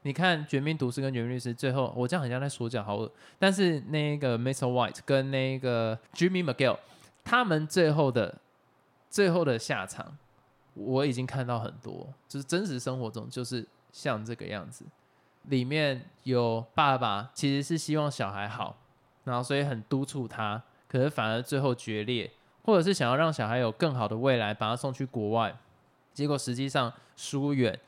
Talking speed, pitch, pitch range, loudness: 290 characters per minute, 130 Hz, 120-145 Hz, -30 LUFS